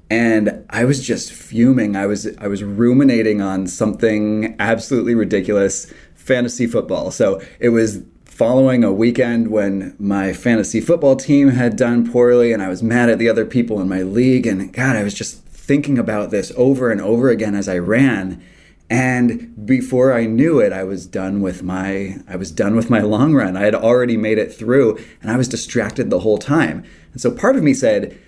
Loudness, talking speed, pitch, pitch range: -16 LUFS, 195 wpm, 115 Hz, 100-120 Hz